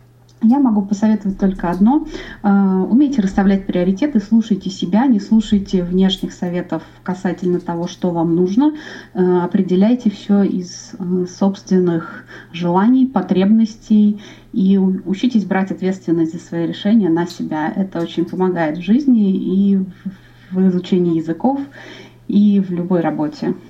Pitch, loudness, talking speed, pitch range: 190 Hz, -16 LUFS, 120 wpm, 180-215 Hz